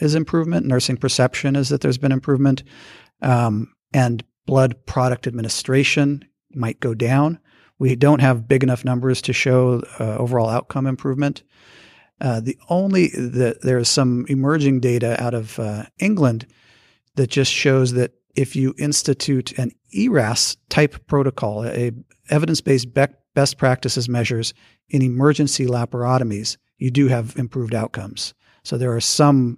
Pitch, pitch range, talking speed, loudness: 130 Hz, 120-140 Hz, 145 wpm, -19 LUFS